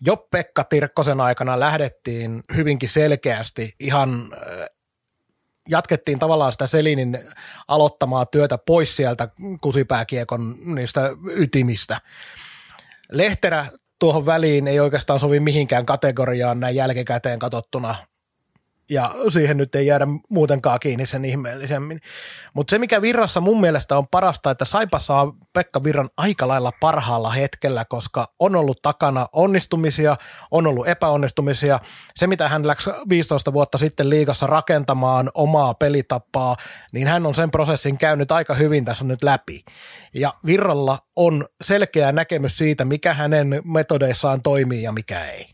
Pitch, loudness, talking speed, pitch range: 145 Hz, -20 LUFS, 130 wpm, 130-160 Hz